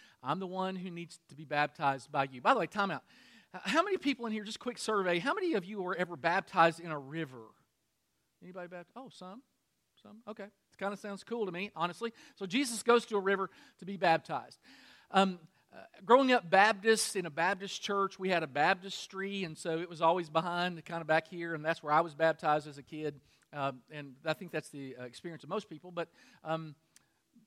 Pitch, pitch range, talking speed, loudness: 180 Hz, 160-205 Hz, 225 wpm, -33 LUFS